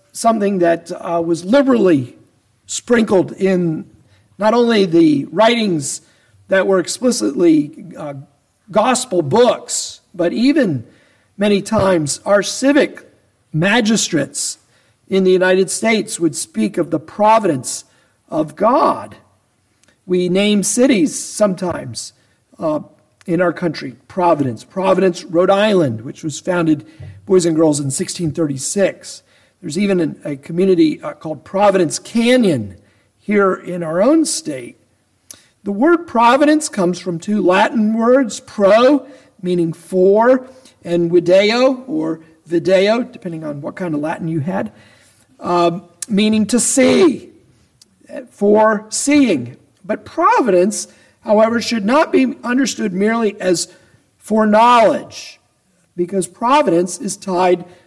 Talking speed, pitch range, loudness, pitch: 115 wpm, 165-230 Hz, -15 LUFS, 190 Hz